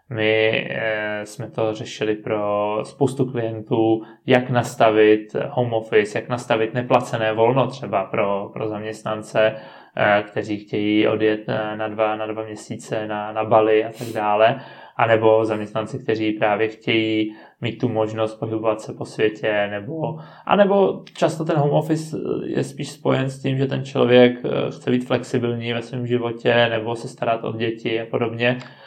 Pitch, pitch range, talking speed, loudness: 110 Hz, 110-125 Hz, 155 wpm, -21 LUFS